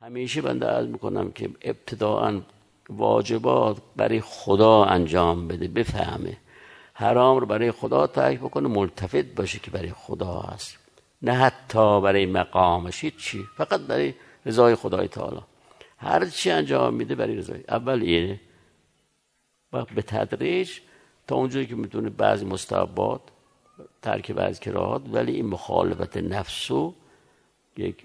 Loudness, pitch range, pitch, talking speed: -24 LUFS, 90-125 Hz, 105 Hz, 125 wpm